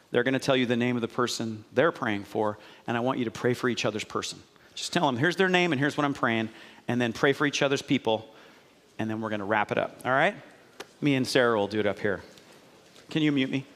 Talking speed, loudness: 275 wpm, -27 LUFS